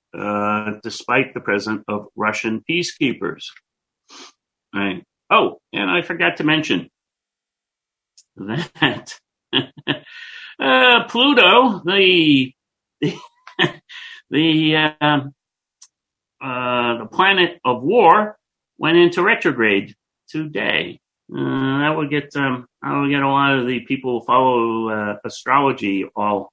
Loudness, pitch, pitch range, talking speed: -18 LUFS, 135 Hz, 110-160 Hz, 105 wpm